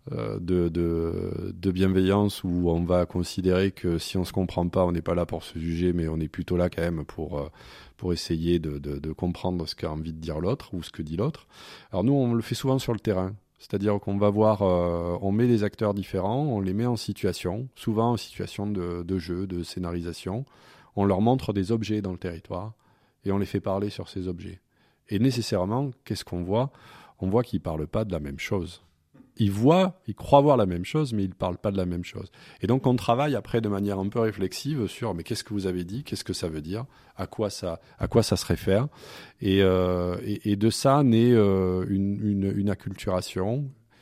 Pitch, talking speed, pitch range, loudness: 95 Hz, 230 wpm, 90-115 Hz, -27 LUFS